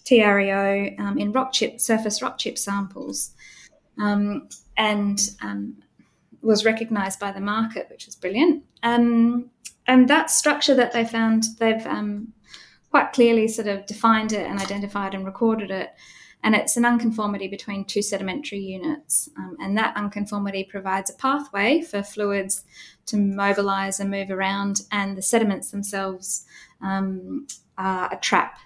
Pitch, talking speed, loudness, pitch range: 205 Hz, 145 wpm, -22 LUFS, 195-230 Hz